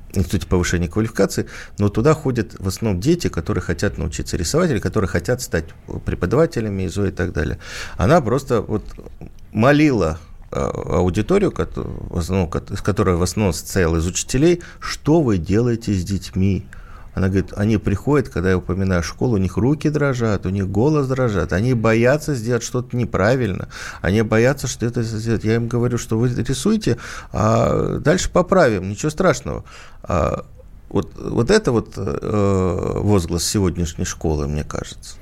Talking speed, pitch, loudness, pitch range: 145 wpm, 100 Hz, -20 LUFS, 90-120 Hz